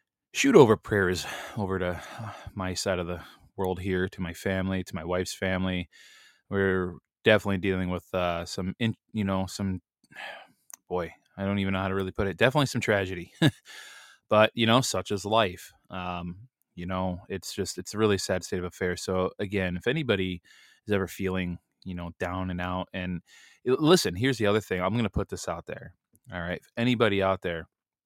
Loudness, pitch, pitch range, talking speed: -28 LUFS, 95 Hz, 90-100 Hz, 190 wpm